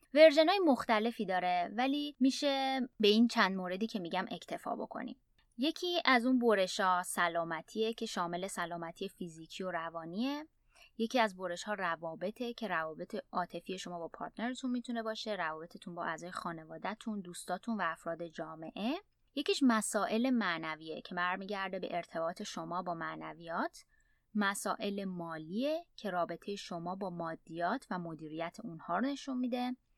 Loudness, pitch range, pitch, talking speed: -35 LUFS, 175-235 Hz, 200 Hz, 140 wpm